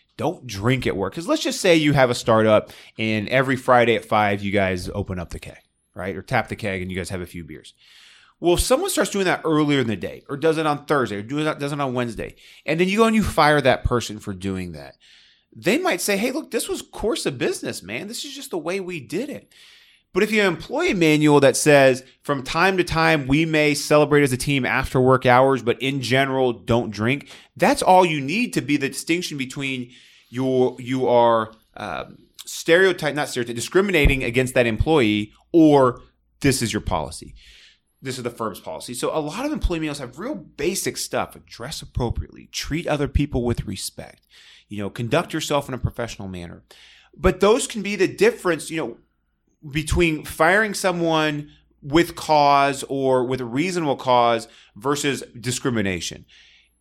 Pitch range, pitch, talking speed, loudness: 115-160 Hz, 135 Hz, 200 wpm, -21 LUFS